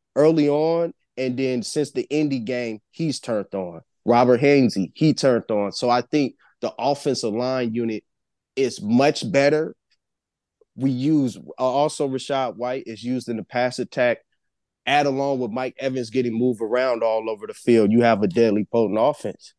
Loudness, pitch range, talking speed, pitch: -22 LUFS, 120-140 Hz, 170 wpm, 130 Hz